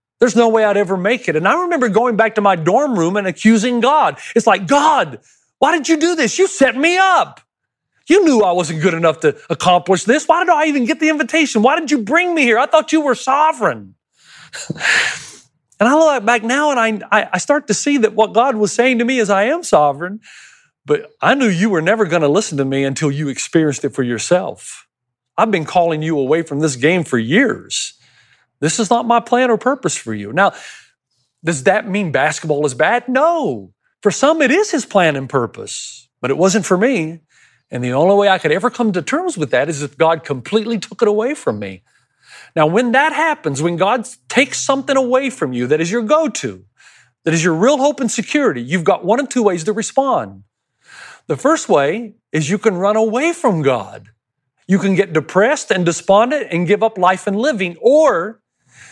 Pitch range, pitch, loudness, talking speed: 160-260 Hz, 210 Hz, -15 LUFS, 215 wpm